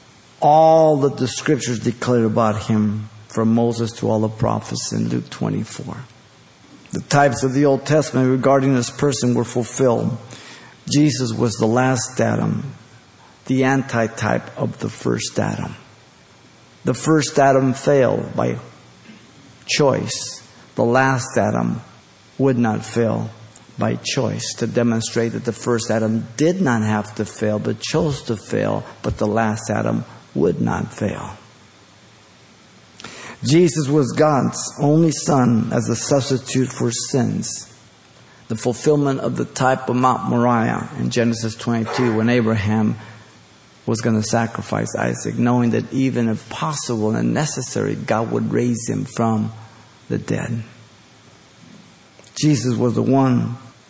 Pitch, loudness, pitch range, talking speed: 120 Hz, -19 LUFS, 110-130 Hz, 135 wpm